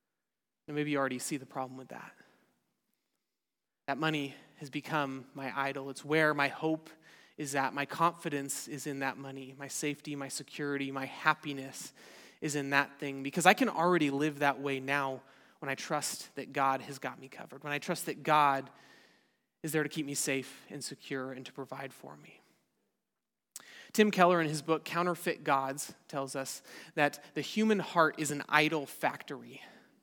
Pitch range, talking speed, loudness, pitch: 135-155 Hz, 180 wpm, -33 LUFS, 145 Hz